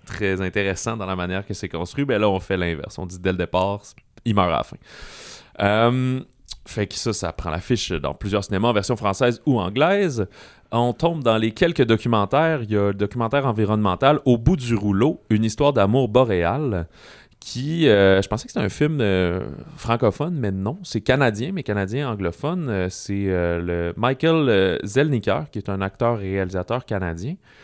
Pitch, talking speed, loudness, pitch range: 105 Hz, 190 wpm, -21 LUFS, 95-130 Hz